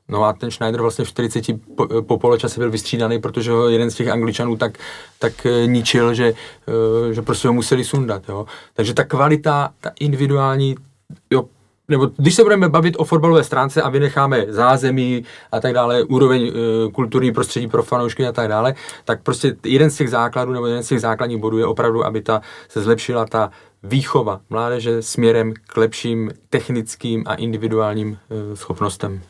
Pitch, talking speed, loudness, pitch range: 120 Hz, 170 wpm, -18 LUFS, 115-130 Hz